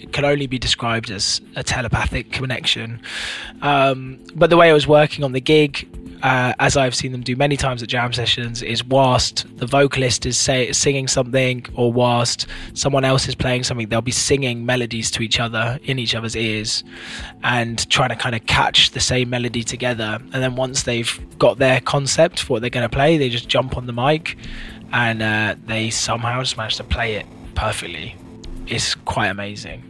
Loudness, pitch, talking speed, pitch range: -18 LUFS, 125 Hz, 195 wpm, 115-135 Hz